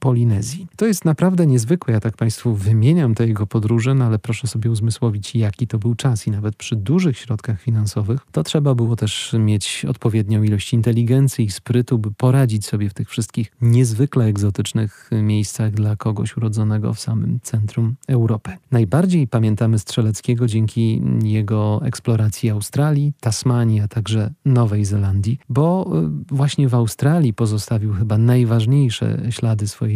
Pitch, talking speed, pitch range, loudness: 115 Hz, 150 wpm, 110-125 Hz, -18 LUFS